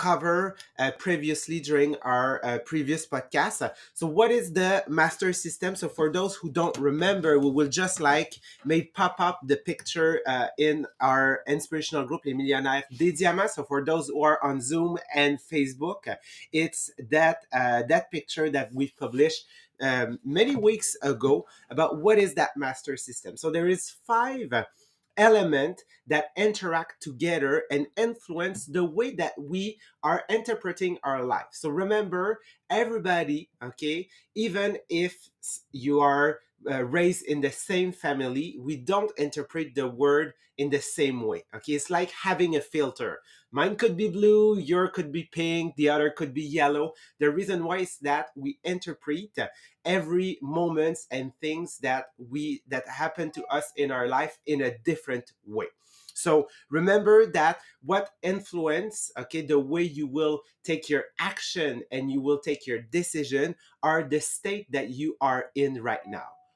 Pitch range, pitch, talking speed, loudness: 145-180 Hz, 160 Hz, 160 wpm, -27 LUFS